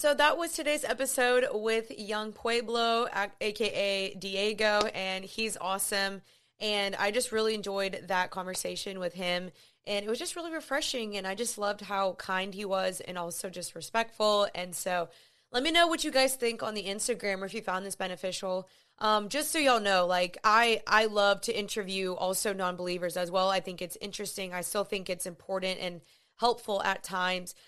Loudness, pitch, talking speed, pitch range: -30 LUFS, 200 Hz, 185 wpm, 185-225 Hz